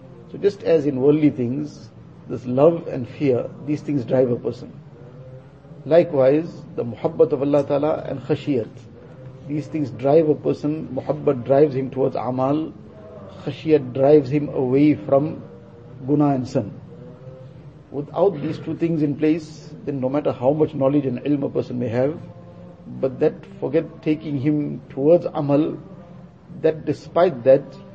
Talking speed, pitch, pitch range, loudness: 150 wpm, 145 Hz, 130-155 Hz, -21 LUFS